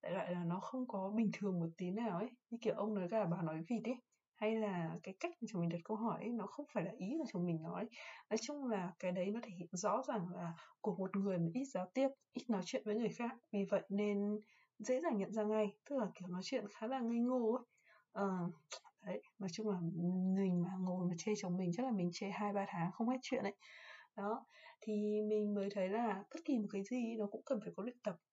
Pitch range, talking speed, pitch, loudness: 185-235 Hz, 265 wpm, 210 Hz, -41 LUFS